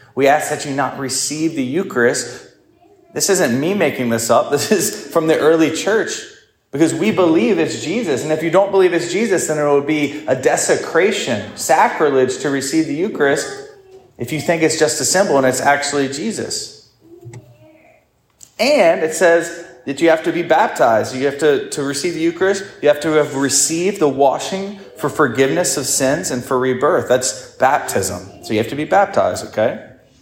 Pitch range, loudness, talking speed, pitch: 140-185 Hz, -16 LUFS, 185 wpm, 155 Hz